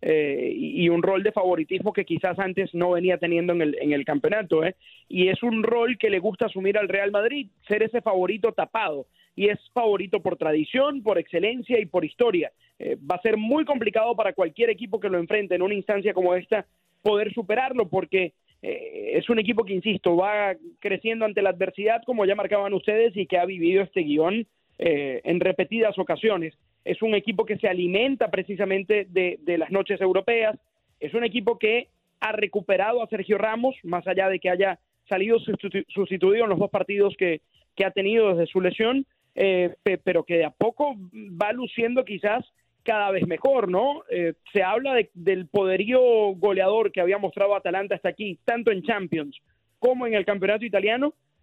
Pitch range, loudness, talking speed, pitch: 185-225 Hz, -24 LUFS, 190 wpm, 200 Hz